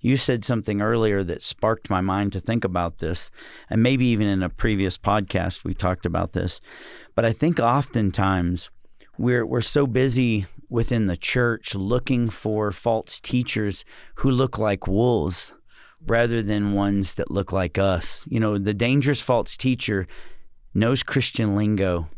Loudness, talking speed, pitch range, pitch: -23 LUFS, 155 wpm, 95-120 Hz, 105 Hz